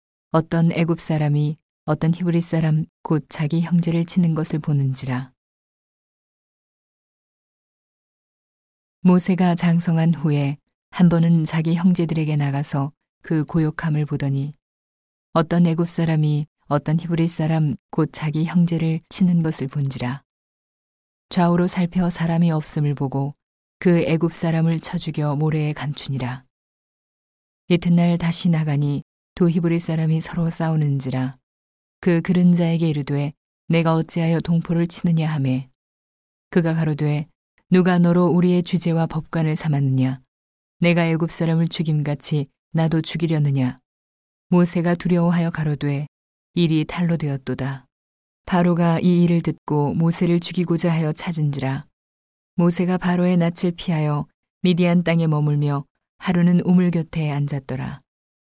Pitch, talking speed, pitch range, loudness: 160 Hz, 275 characters per minute, 145-170 Hz, -21 LUFS